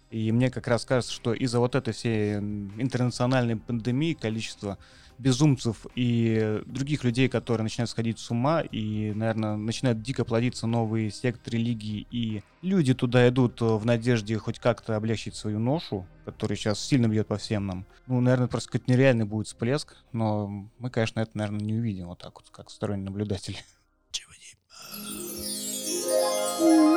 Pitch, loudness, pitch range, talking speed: 115 Hz, -27 LUFS, 105-125 Hz, 150 wpm